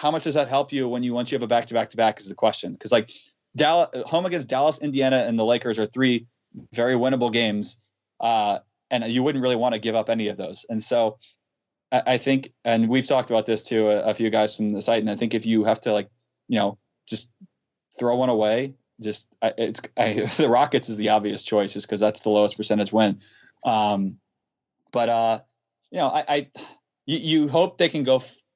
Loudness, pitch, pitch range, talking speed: -23 LUFS, 115 Hz, 110-130 Hz, 225 wpm